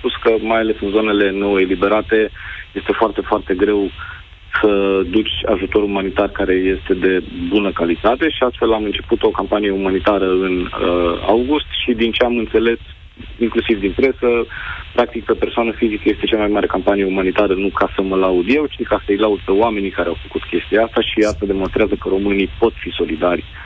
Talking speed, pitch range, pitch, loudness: 190 wpm, 95-110 Hz, 100 Hz, -17 LUFS